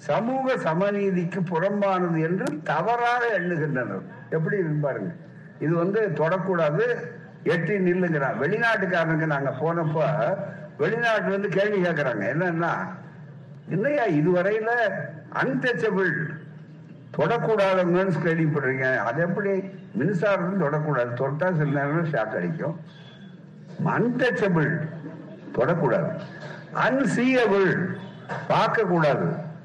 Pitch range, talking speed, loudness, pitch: 155-195 Hz, 75 wpm, -24 LUFS, 175 Hz